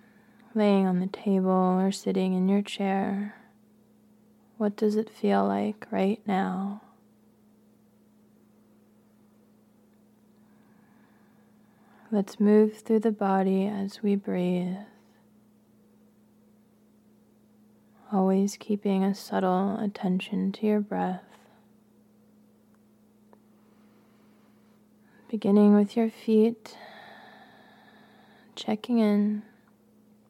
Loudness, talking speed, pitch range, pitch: -26 LUFS, 75 wpm, 205-220 Hz, 215 Hz